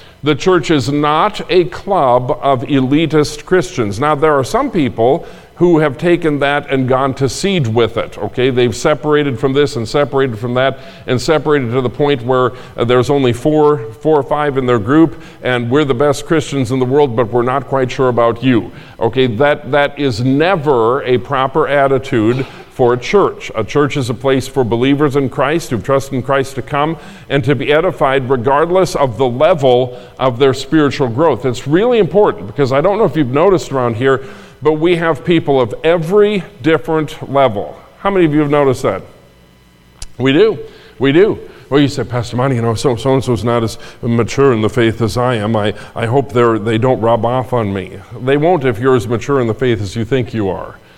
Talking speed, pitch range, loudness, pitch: 205 wpm, 125-150 Hz, -14 LUFS, 135 Hz